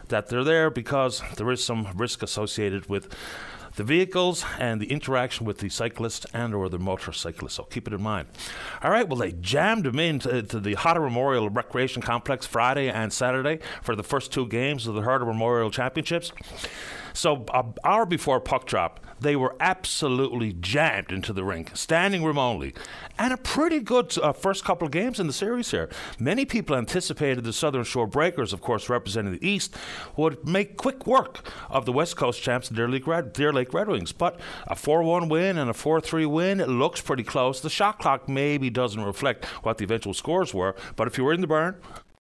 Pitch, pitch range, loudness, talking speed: 130 Hz, 115-160 Hz, -26 LUFS, 195 wpm